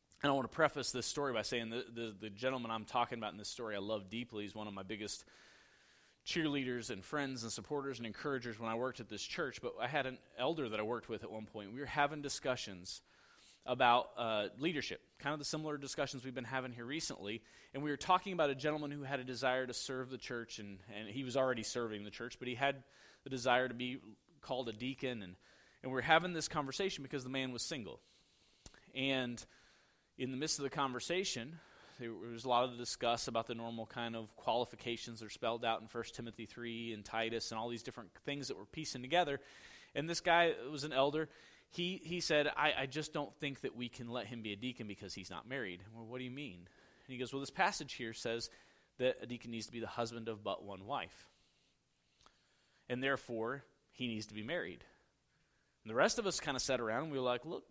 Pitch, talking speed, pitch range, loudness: 125 Hz, 235 wpm, 115-140 Hz, -39 LUFS